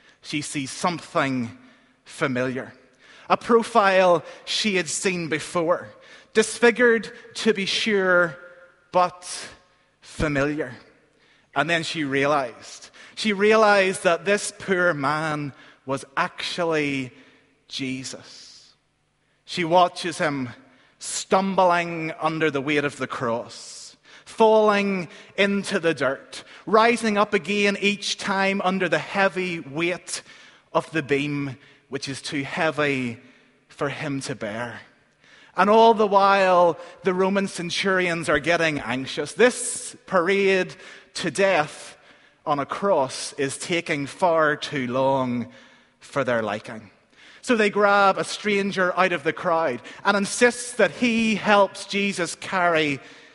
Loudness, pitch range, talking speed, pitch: -22 LUFS, 145-195 Hz, 115 wpm, 175 Hz